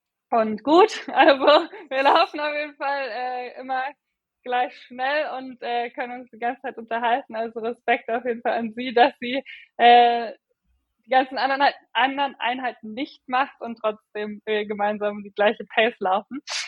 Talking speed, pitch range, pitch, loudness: 160 wpm, 230-275 Hz, 245 Hz, -22 LUFS